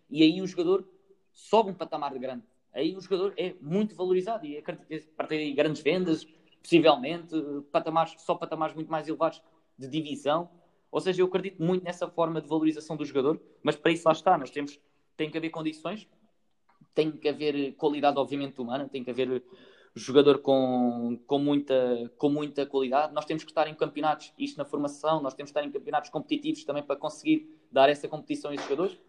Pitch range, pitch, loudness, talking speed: 145-170 Hz, 155 Hz, -29 LUFS, 190 wpm